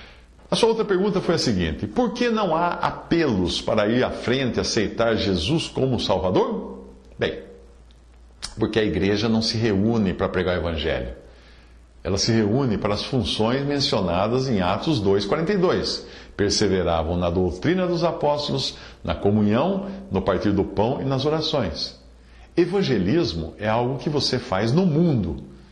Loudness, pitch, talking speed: -22 LUFS, 110 Hz, 150 wpm